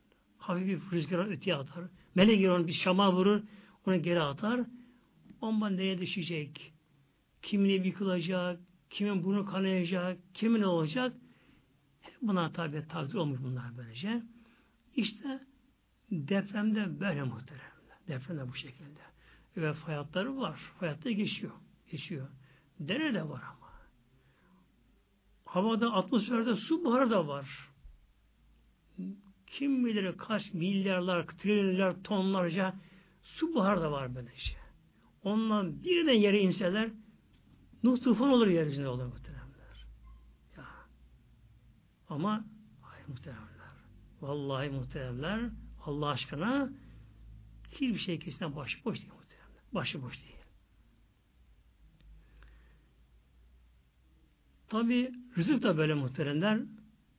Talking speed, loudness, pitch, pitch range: 105 wpm, -32 LUFS, 180 Hz, 140-210 Hz